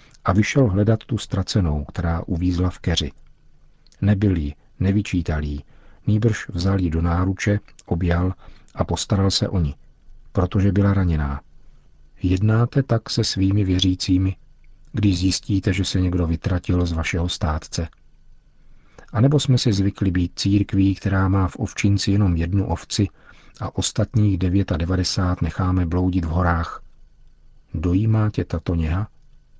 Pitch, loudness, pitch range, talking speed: 95 Hz, -21 LUFS, 85-105 Hz, 135 wpm